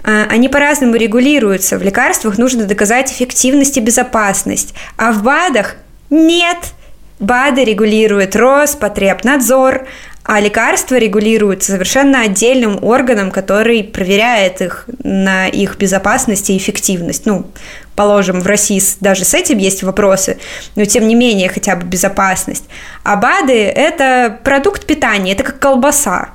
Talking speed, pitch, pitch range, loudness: 125 wpm, 225 Hz, 200-260 Hz, -11 LUFS